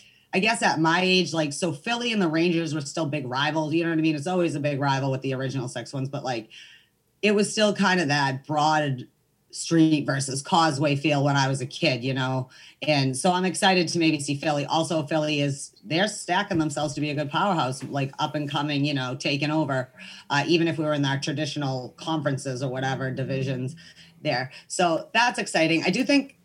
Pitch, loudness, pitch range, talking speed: 150 Hz, -24 LUFS, 135-170 Hz, 220 wpm